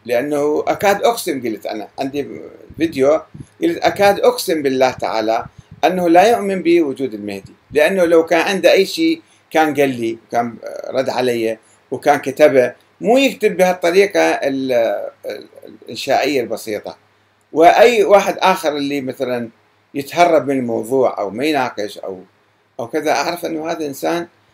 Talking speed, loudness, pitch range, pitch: 130 wpm, -16 LUFS, 125-190 Hz, 150 Hz